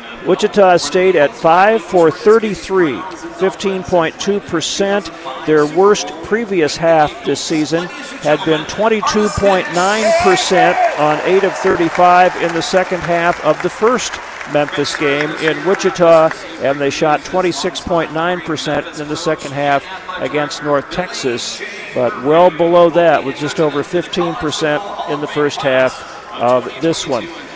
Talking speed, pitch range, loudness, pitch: 125 wpm, 150-185 Hz, -14 LUFS, 170 Hz